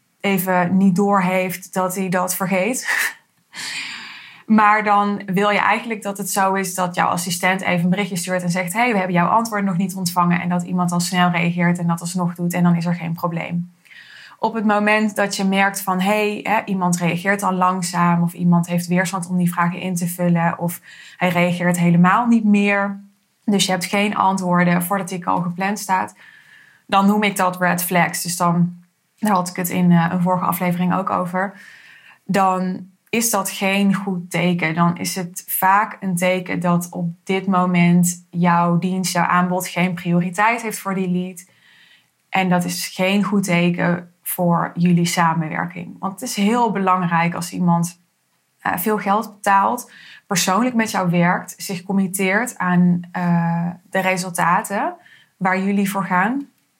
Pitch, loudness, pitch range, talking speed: 185 Hz, -19 LUFS, 175-200 Hz, 175 wpm